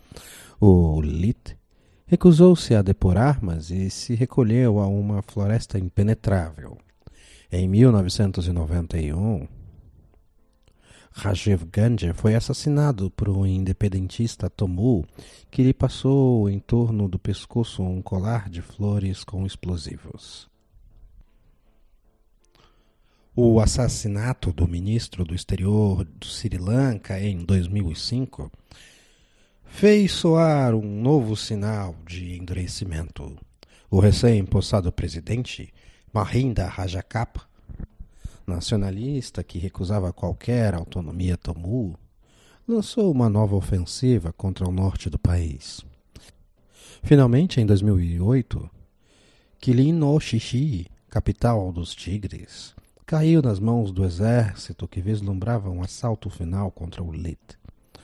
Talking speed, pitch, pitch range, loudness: 100 wpm, 100 Hz, 90-115 Hz, -23 LUFS